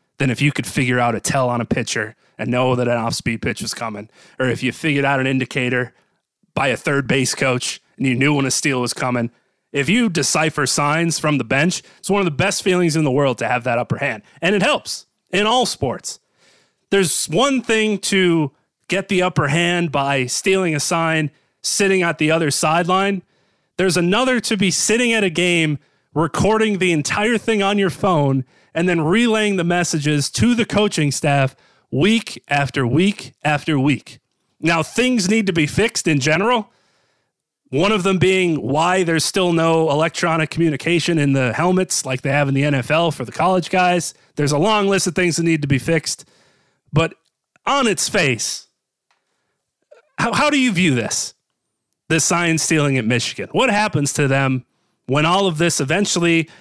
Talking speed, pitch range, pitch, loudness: 190 wpm, 140-185 Hz, 160 Hz, -18 LUFS